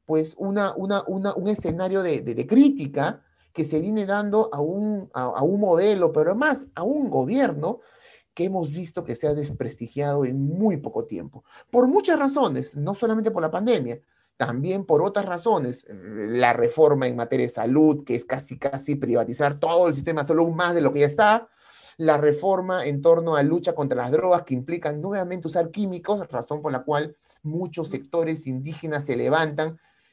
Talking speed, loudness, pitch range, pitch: 185 wpm, -23 LUFS, 145-195 Hz, 165 Hz